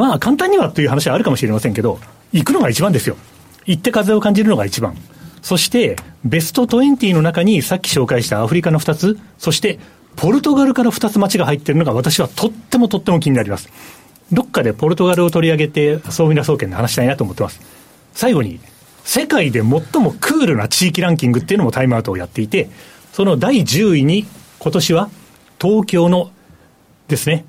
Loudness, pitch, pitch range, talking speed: -15 LUFS, 165 Hz, 140-205 Hz, 400 characters per minute